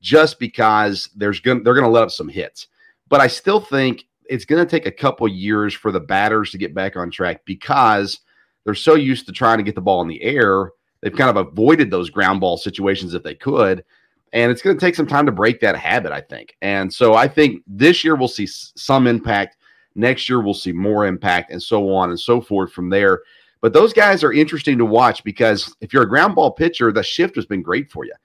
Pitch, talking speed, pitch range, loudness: 115 Hz, 240 wpm, 100-150 Hz, -16 LUFS